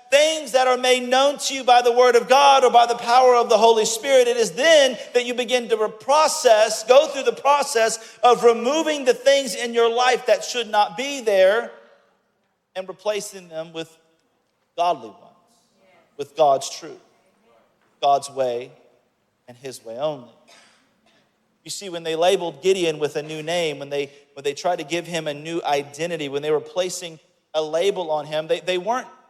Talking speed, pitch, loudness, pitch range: 185 wpm, 200 Hz, -19 LUFS, 160-250 Hz